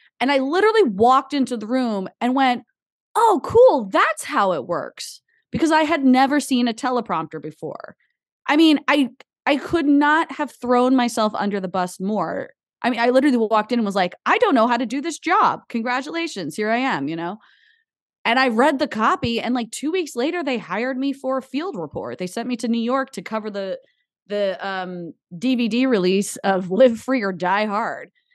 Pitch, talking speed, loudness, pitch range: 250 Hz, 200 wpm, -20 LUFS, 215-285 Hz